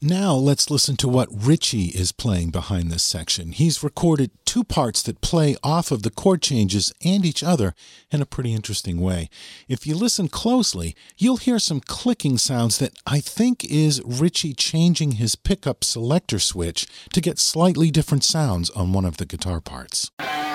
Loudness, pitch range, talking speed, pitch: -21 LUFS, 100-165 Hz, 175 wpm, 140 Hz